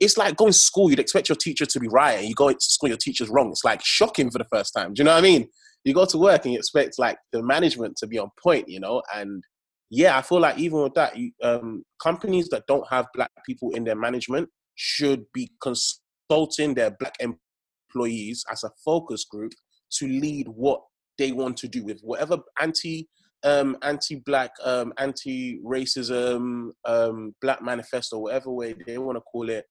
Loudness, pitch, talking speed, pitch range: -23 LUFS, 130 Hz, 205 wpm, 120-160 Hz